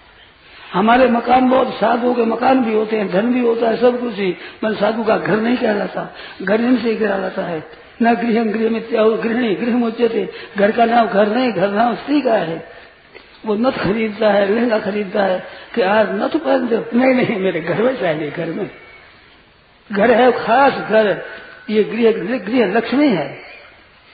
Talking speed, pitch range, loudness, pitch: 175 wpm, 205-240 Hz, -16 LUFS, 225 Hz